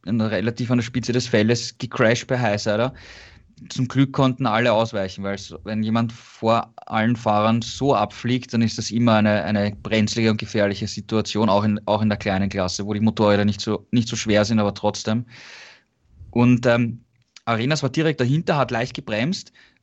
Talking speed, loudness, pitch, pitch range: 180 wpm, -21 LUFS, 110 Hz, 105-120 Hz